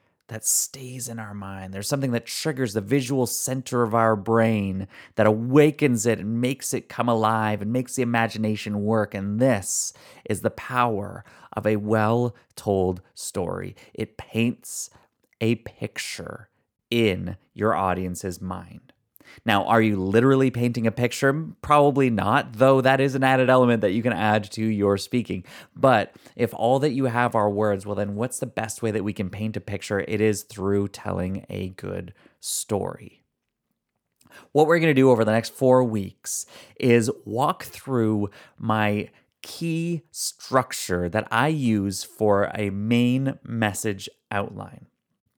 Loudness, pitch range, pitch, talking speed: -23 LUFS, 105-125 Hz, 110 Hz, 155 wpm